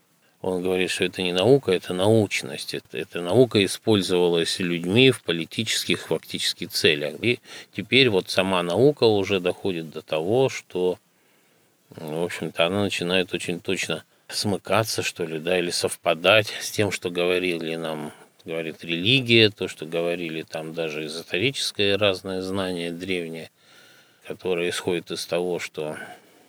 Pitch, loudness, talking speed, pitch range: 90 Hz, -23 LUFS, 140 wpm, 85-100 Hz